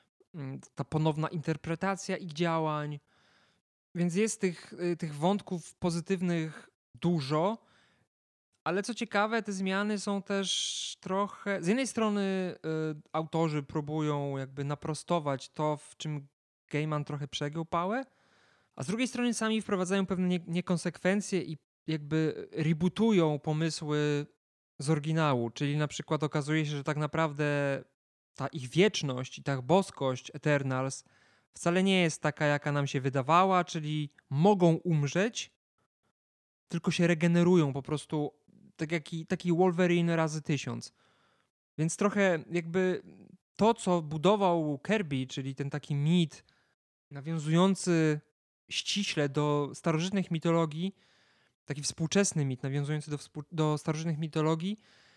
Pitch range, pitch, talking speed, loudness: 150-185 Hz, 160 Hz, 120 wpm, -31 LUFS